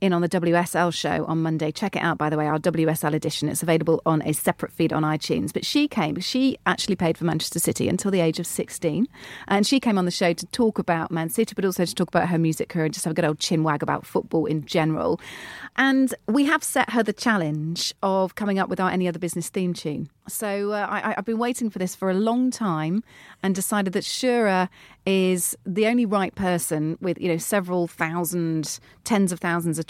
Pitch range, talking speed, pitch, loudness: 160-205 Hz, 235 wpm, 180 Hz, -24 LUFS